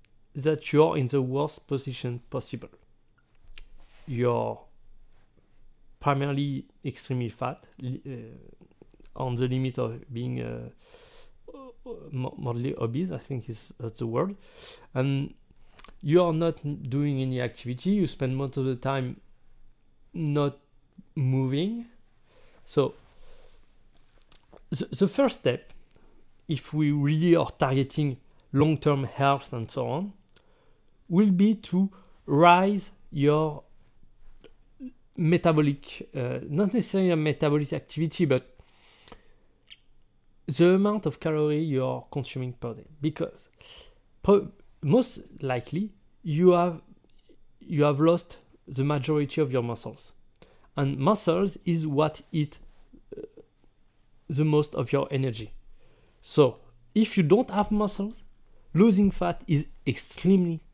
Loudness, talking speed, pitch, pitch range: -27 LUFS, 115 wpm, 145 Hz, 130-175 Hz